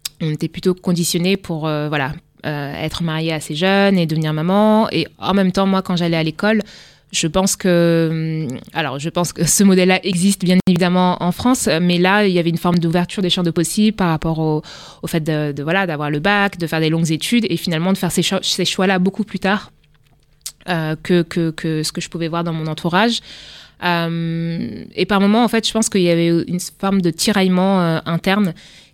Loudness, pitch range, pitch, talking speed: -17 LUFS, 160-190 Hz, 175 Hz, 220 wpm